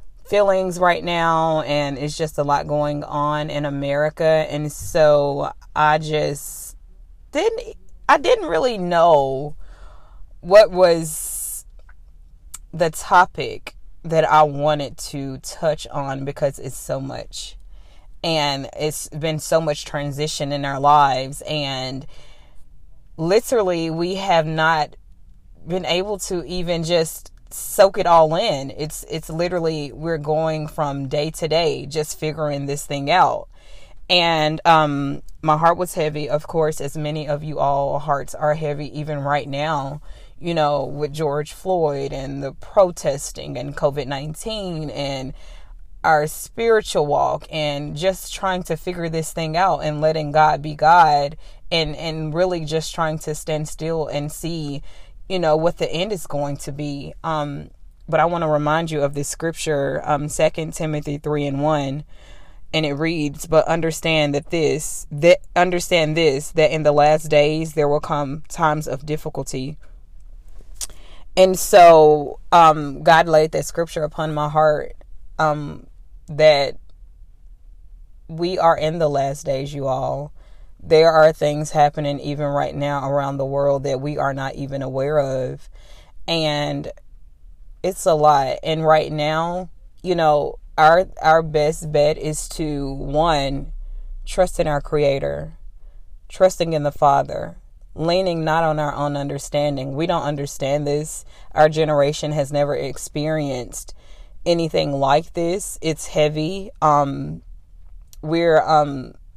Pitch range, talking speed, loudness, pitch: 140-160 Hz, 140 wpm, -19 LUFS, 150 Hz